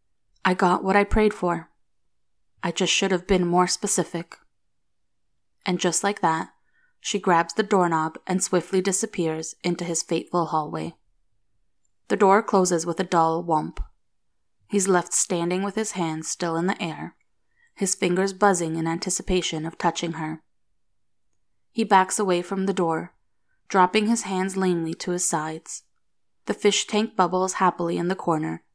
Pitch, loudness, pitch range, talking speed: 175 Hz, -23 LUFS, 160-190 Hz, 155 wpm